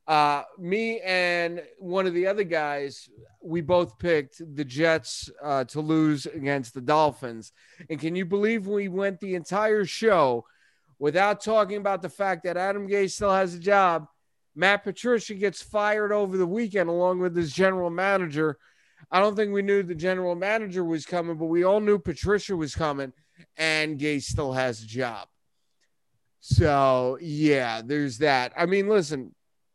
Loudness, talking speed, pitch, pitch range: -25 LUFS, 165 wpm, 175 Hz, 150-195 Hz